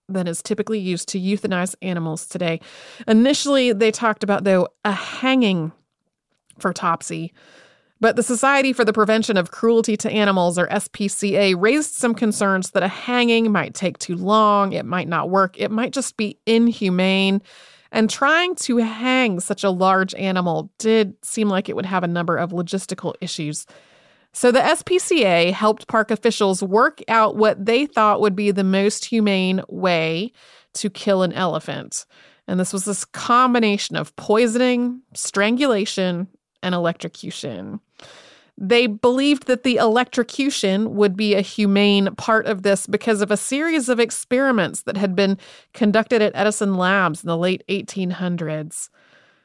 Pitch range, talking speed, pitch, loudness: 185-230 Hz, 155 wpm, 205 Hz, -19 LUFS